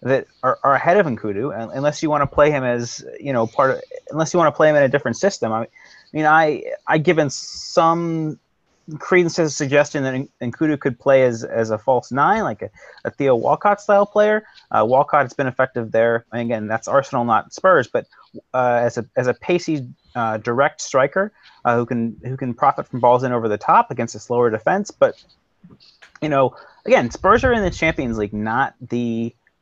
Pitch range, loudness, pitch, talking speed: 120-160 Hz, -19 LUFS, 135 Hz, 215 wpm